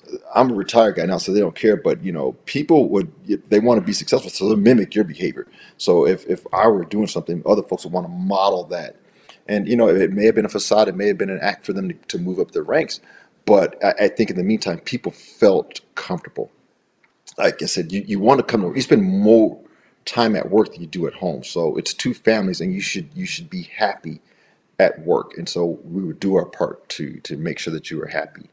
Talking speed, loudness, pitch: 250 wpm, -19 LUFS, 165 Hz